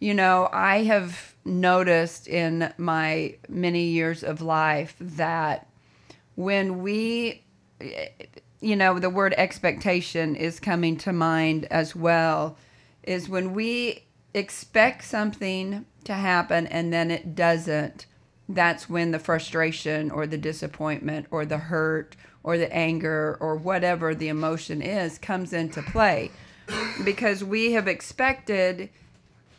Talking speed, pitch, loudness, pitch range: 125 wpm, 170 Hz, -25 LUFS, 160-190 Hz